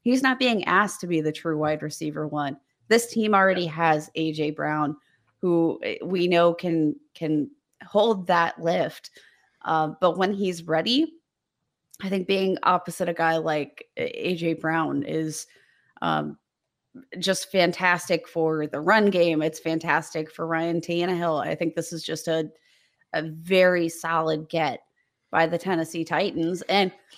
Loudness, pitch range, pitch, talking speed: -24 LUFS, 160-190 Hz, 170 Hz, 150 wpm